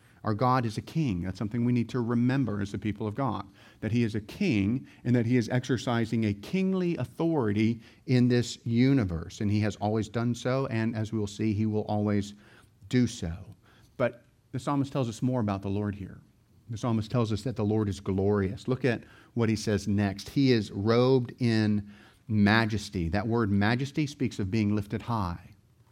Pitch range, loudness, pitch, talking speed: 105-125 Hz, -29 LUFS, 115 Hz, 195 wpm